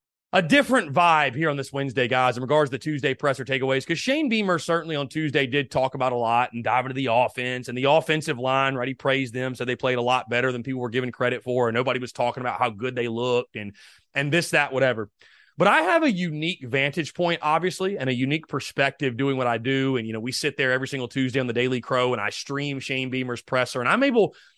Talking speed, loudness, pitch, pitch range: 250 wpm, -24 LUFS, 135 Hz, 125-150 Hz